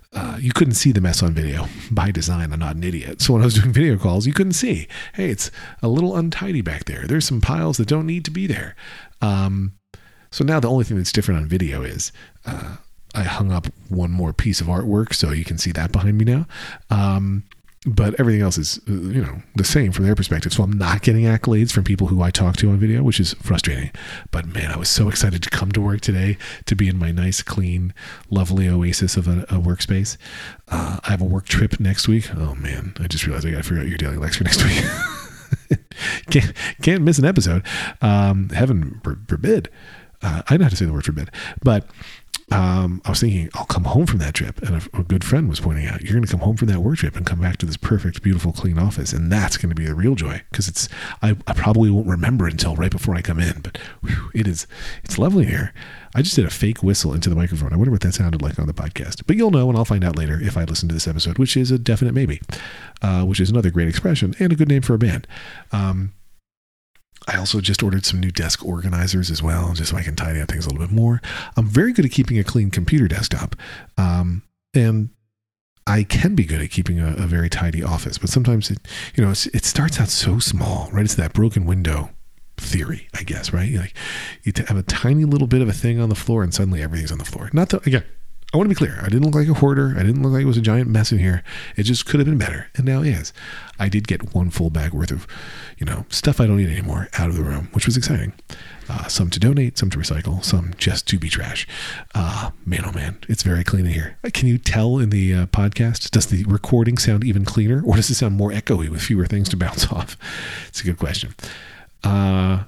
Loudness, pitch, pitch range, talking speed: -20 LUFS, 100 Hz, 90-115 Hz, 250 wpm